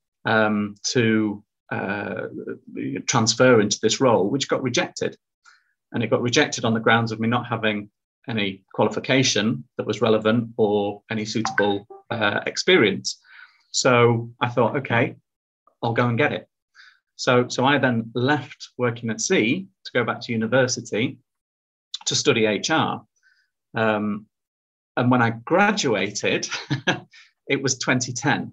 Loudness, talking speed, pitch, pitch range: -22 LUFS, 135 wpm, 115 Hz, 110-125 Hz